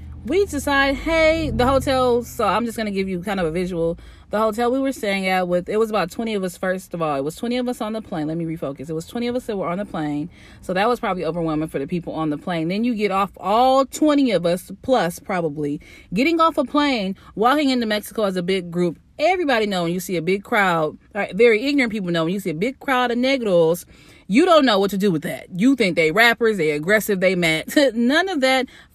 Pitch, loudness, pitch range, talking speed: 205 Hz, -20 LUFS, 175-250 Hz, 260 wpm